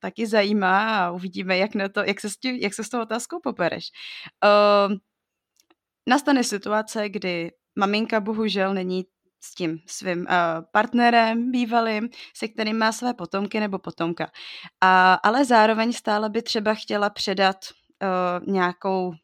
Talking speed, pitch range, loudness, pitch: 145 wpm, 185-225 Hz, -22 LUFS, 205 Hz